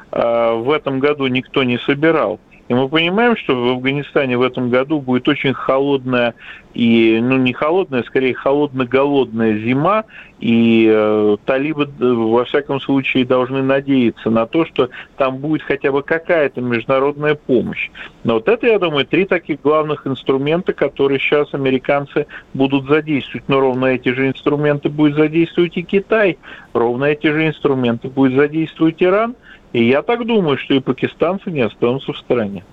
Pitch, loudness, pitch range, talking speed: 135 Hz, -16 LUFS, 125-155 Hz, 155 wpm